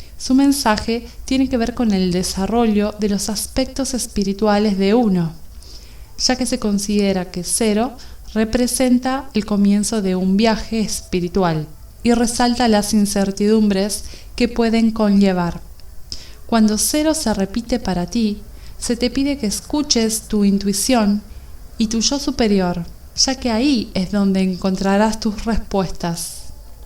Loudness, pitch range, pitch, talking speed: -18 LUFS, 195-240 Hz, 215 Hz, 130 wpm